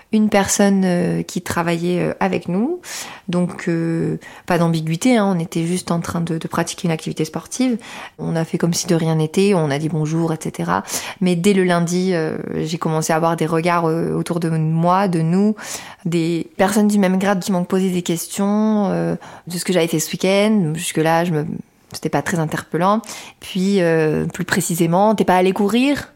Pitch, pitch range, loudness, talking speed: 175 Hz, 165-195 Hz, -19 LUFS, 195 wpm